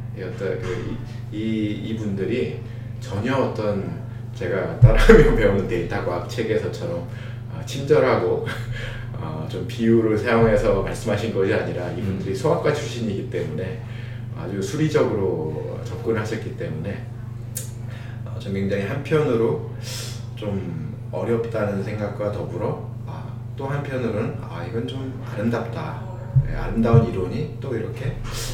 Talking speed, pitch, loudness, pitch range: 275 characters per minute, 120 Hz, -23 LUFS, 115-120 Hz